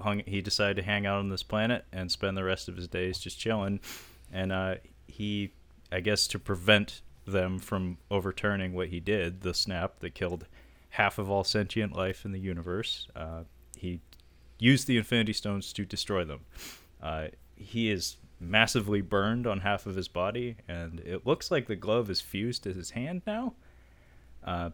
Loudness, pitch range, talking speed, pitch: -31 LUFS, 85-105 Hz, 180 wpm, 95 Hz